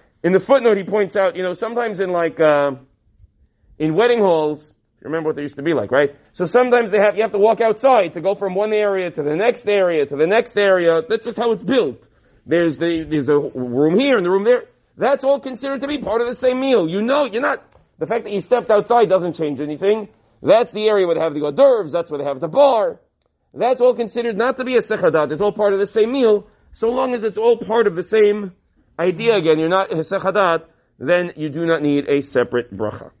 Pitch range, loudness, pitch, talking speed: 155-230 Hz, -18 LUFS, 195 Hz, 250 wpm